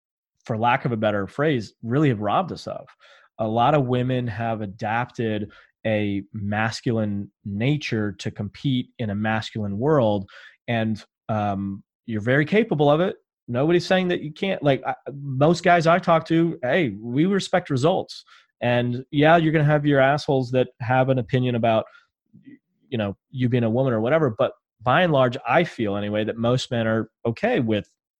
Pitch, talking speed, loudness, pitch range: 125 Hz, 175 wpm, -22 LUFS, 110-155 Hz